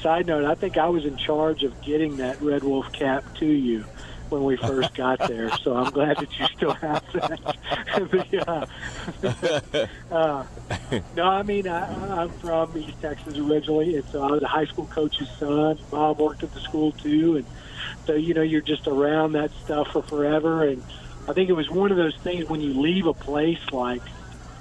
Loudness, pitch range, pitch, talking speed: -25 LUFS, 140-160 Hz, 150 Hz, 200 wpm